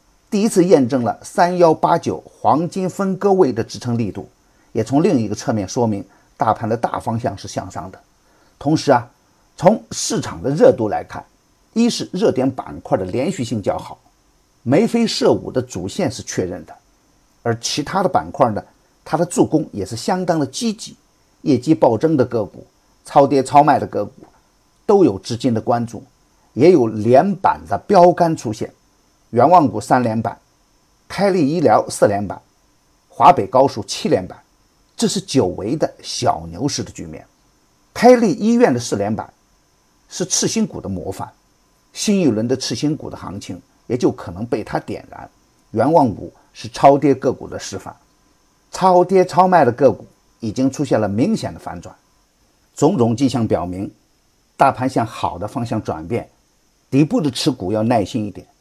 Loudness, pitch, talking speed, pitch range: -17 LUFS, 140 Hz, 245 characters per minute, 115-180 Hz